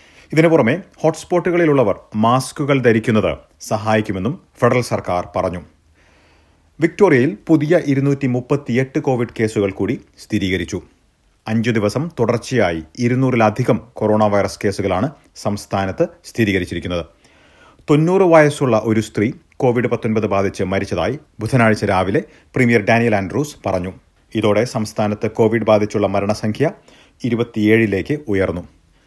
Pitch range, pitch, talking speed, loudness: 100-130 Hz, 110 Hz, 95 wpm, -17 LUFS